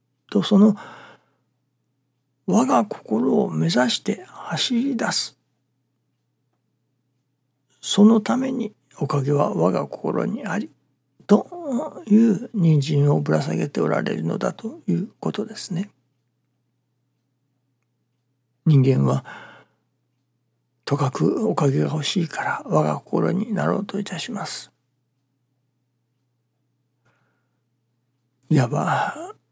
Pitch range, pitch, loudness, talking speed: 125-180 Hz, 130 Hz, -22 LUFS, 175 characters per minute